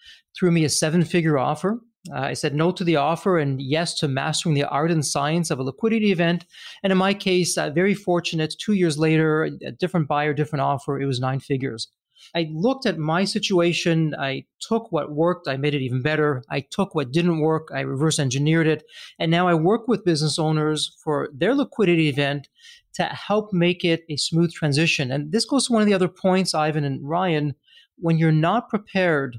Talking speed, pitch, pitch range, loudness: 205 wpm, 165 Hz, 150-185 Hz, -22 LUFS